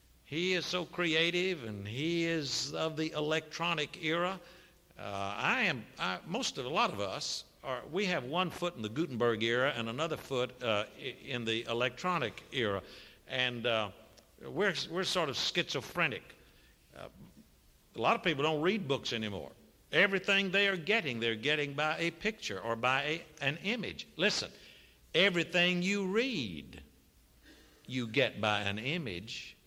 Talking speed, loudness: 155 wpm, -33 LUFS